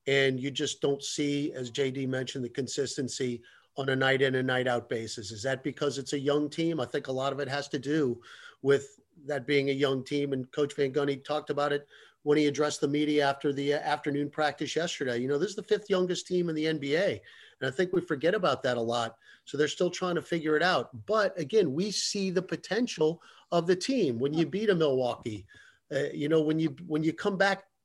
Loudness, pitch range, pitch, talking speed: -29 LUFS, 135-160 Hz, 145 Hz, 235 wpm